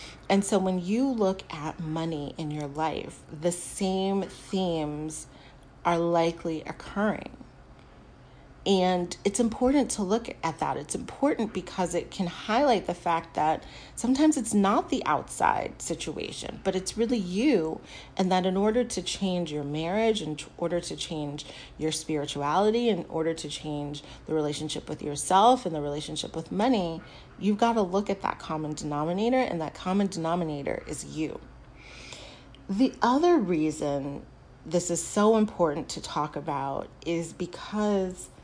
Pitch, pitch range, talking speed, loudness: 170 Hz, 155-200 Hz, 150 wpm, -28 LUFS